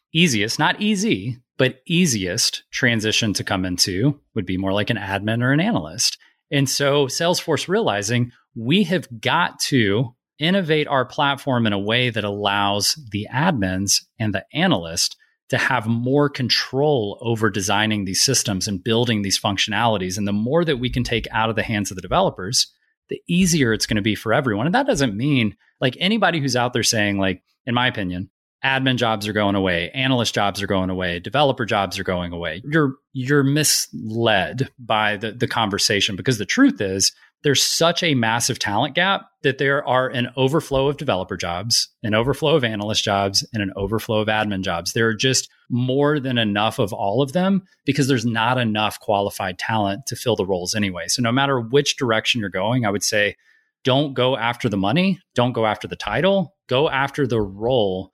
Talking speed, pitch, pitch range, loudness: 190 wpm, 120 Hz, 105-140 Hz, -20 LUFS